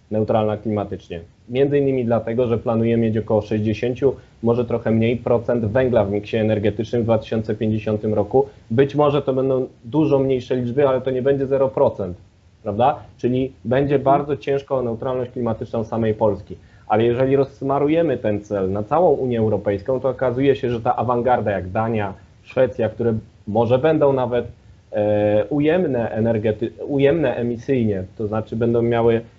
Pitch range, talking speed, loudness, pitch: 110-130 Hz, 150 wpm, -20 LUFS, 115 Hz